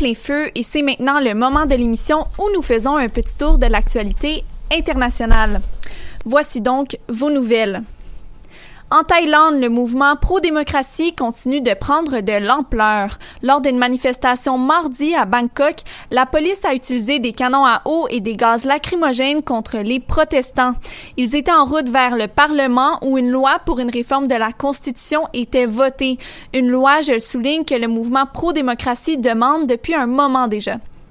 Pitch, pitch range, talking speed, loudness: 265 Hz, 245-295 Hz, 165 wpm, -16 LUFS